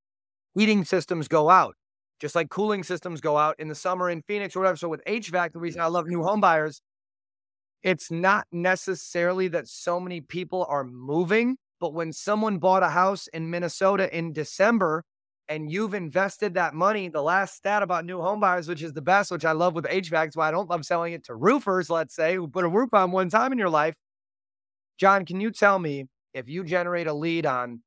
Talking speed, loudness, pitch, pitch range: 210 wpm, -25 LUFS, 175 Hz, 155-190 Hz